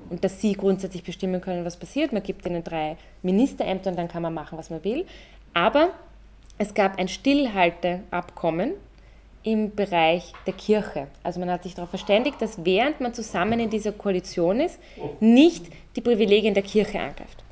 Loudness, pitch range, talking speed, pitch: -24 LUFS, 175-220 Hz, 170 wpm, 190 Hz